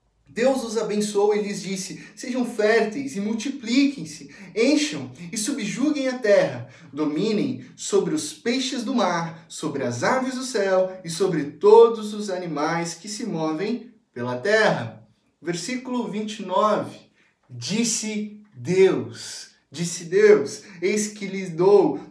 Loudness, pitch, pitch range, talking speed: -23 LUFS, 210 Hz, 170-235 Hz, 125 wpm